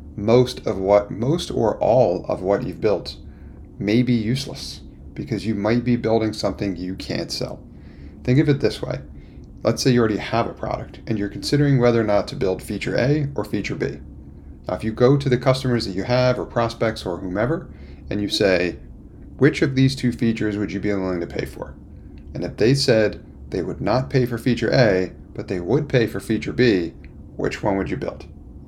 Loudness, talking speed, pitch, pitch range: -21 LUFS, 205 wpm, 110 Hz, 90-125 Hz